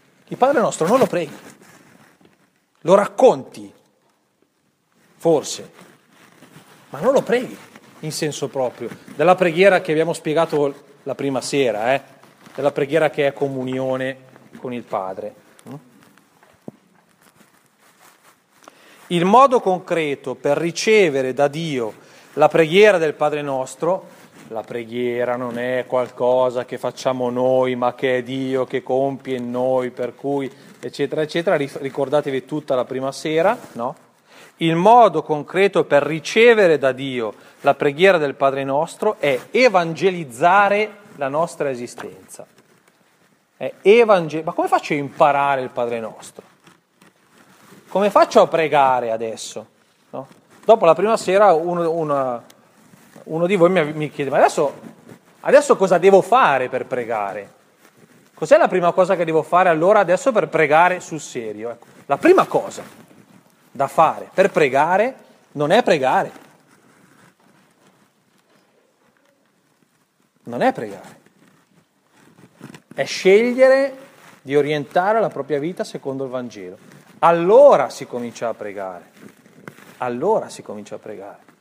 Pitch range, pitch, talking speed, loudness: 130-180 Hz, 145 Hz, 125 wpm, -18 LUFS